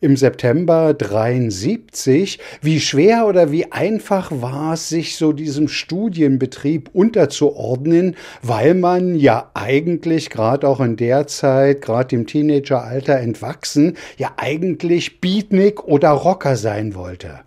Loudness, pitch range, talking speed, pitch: -17 LUFS, 130-165 Hz, 120 wpm, 150 Hz